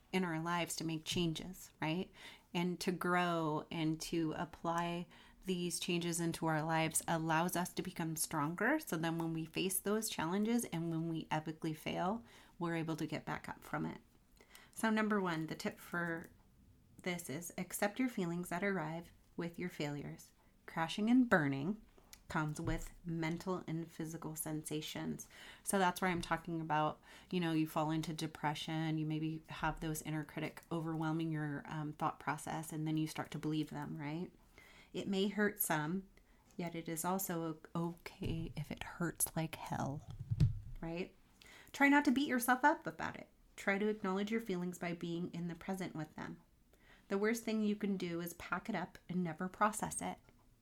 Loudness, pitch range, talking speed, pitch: -39 LUFS, 155-185 Hz, 175 wpm, 170 Hz